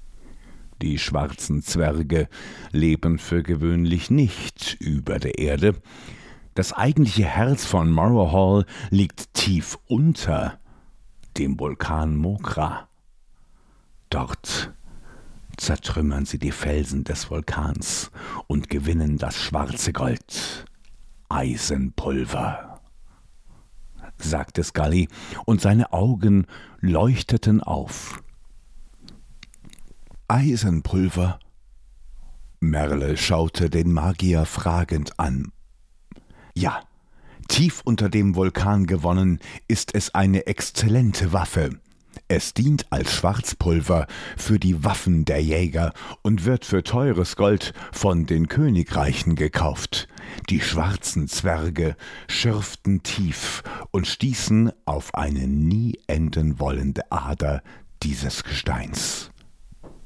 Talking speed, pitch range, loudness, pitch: 90 wpm, 75-100 Hz, -23 LUFS, 85 Hz